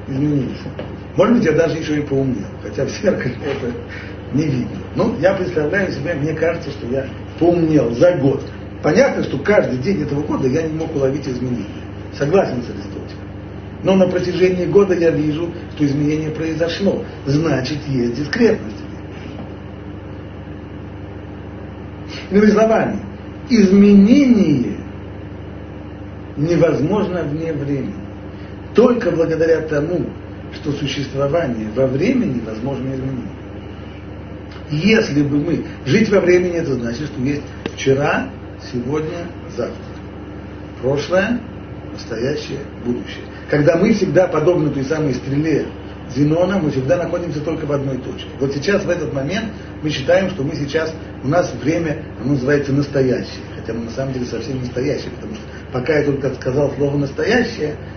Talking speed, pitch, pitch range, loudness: 135 wpm, 135 Hz, 100-160 Hz, -18 LUFS